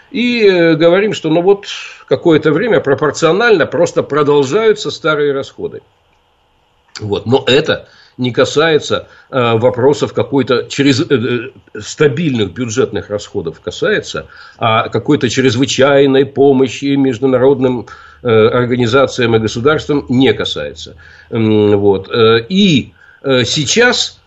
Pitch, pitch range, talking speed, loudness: 140 Hz, 125-195 Hz, 90 wpm, -12 LUFS